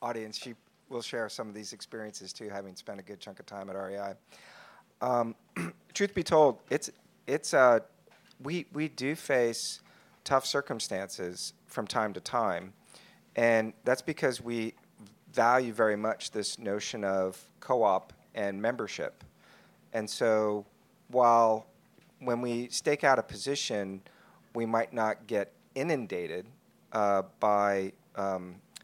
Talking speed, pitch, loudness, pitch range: 135 wpm, 110 Hz, -31 LUFS, 100-125 Hz